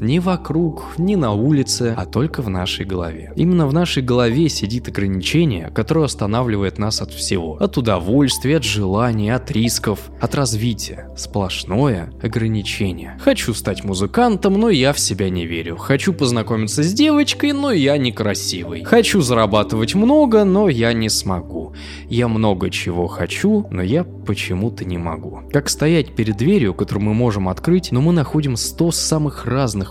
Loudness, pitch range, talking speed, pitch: -18 LUFS, 95-155 Hz, 155 wpm, 115 Hz